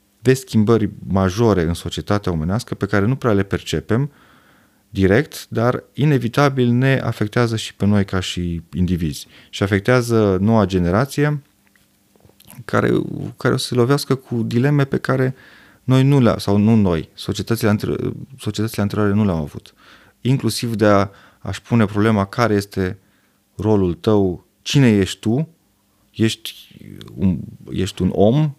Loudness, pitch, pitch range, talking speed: -18 LUFS, 105 Hz, 95-120 Hz, 140 wpm